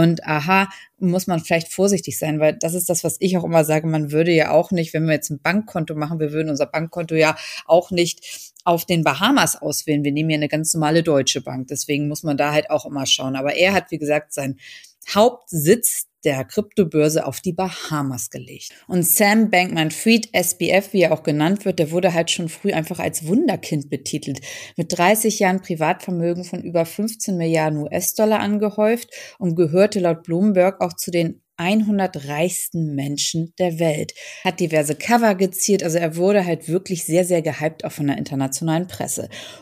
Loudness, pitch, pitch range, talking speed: -20 LUFS, 170 Hz, 155-185 Hz, 190 wpm